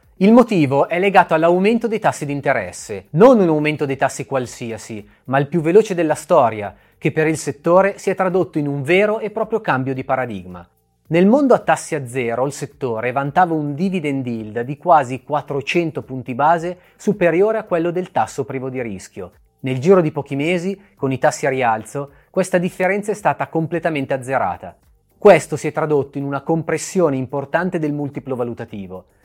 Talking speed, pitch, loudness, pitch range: 180 wpm, 150 Hz, -18 LUFS, 135-180 Hz